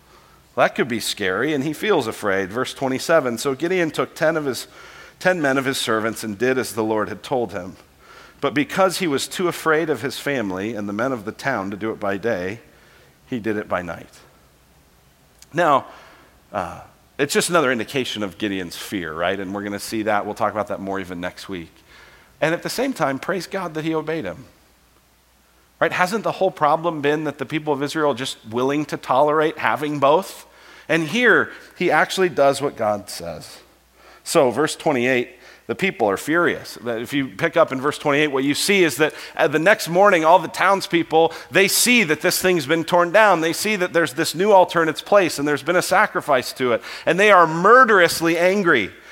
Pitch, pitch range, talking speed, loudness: 145 Hz, 110-170 Hz, 210 wpm, -19 LUFS